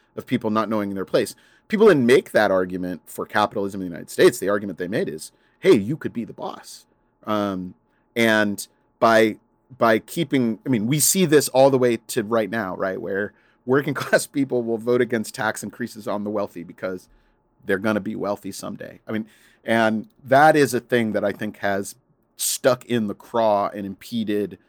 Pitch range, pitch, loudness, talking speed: 100-120 Hz, 110 Hz, -21 LUFS, 195 wpm